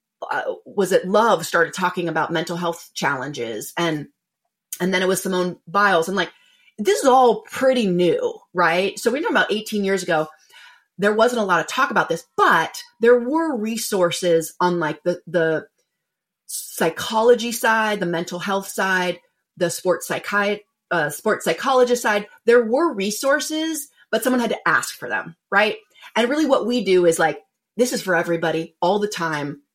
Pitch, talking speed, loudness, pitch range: 195 Hz, 175 wpm, -20 LUFS, 170-240 Hz